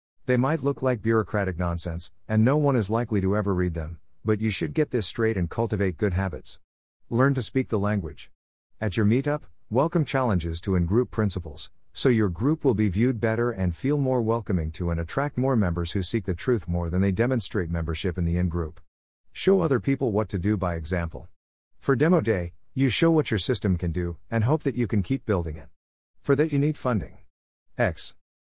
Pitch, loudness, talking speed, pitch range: 105 Hz, -25 LUFS, 205 wpm, 85-125 Hz